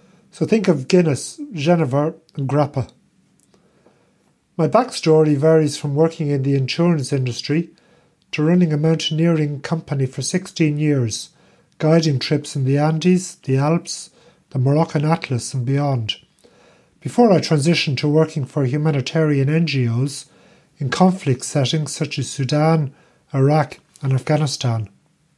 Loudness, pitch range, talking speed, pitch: -19 LUFS, 140-165 Hz, 125 wpm, 155 Hz